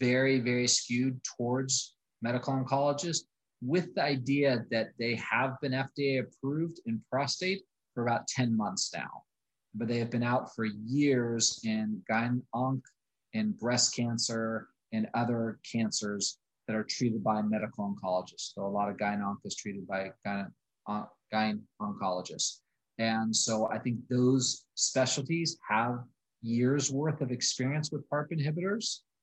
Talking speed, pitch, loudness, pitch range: 145 wpm, 125 Hz, -31 LUFS, 110-140 Hz